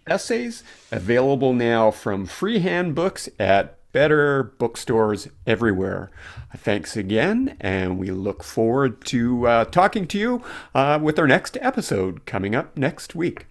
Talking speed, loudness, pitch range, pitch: 135 wpm, -21 LUFS, 105-165 Hz, 120 Hz